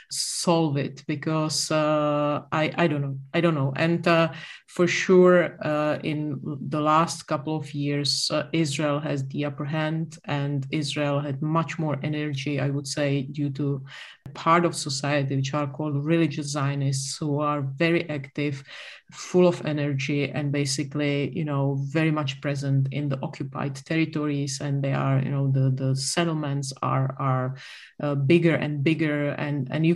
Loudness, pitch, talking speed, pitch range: -25 LUFS, 145 Hz, 165 wpm, 140-155 Hz